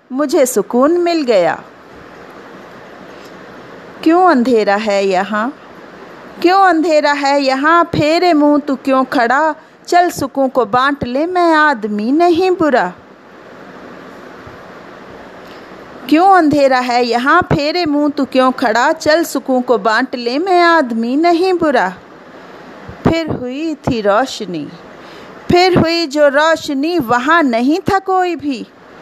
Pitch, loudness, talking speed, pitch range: 290 Hz, -13 LUFS, 120 wpm, 250-330 Hz